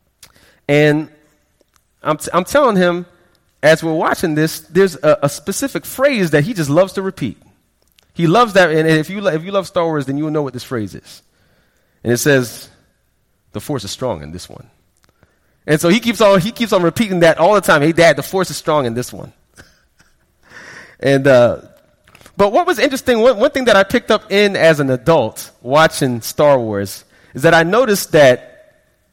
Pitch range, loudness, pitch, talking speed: 145-195 Hz, -14 LUFS, 165 Hz, 200 wpm